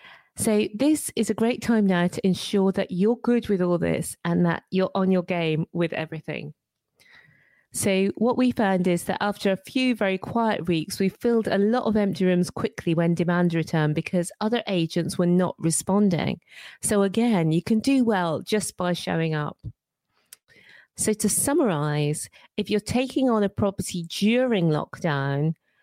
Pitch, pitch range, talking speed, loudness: 190 Hz, 170-215 Hz, 170 wpm, -24 LUFS